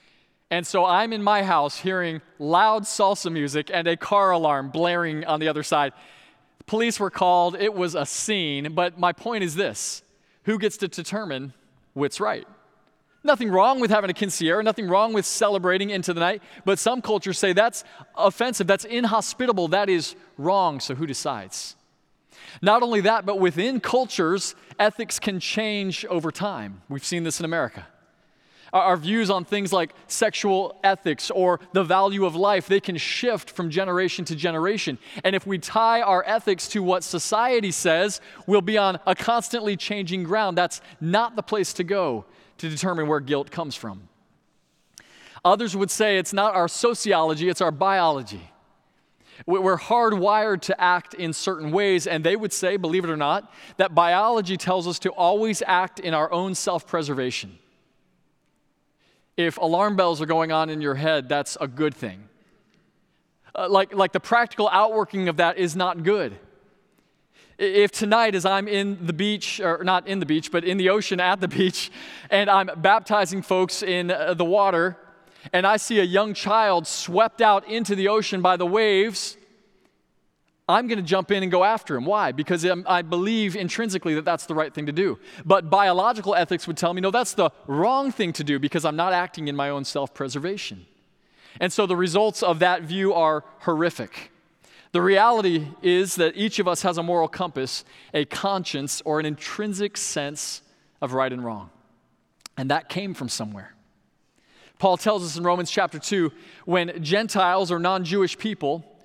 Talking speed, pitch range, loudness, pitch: 175 wpm, 165-205 Hz, -23 LUFS, 185 Hz